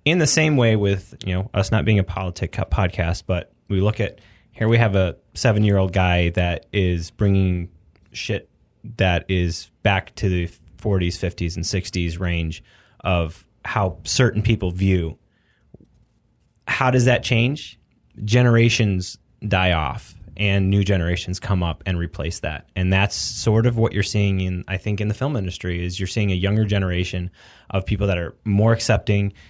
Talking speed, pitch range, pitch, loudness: 170 wpm, 90-110 Hz, 95 Hz, -21 LUFS